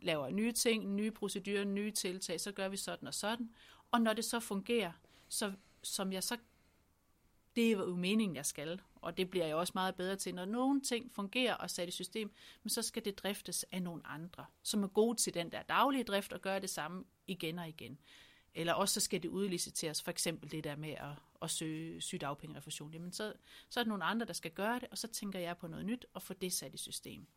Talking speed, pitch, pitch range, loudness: 230 wpm, 190 Hz, 165-215 Hz, -38 LUFS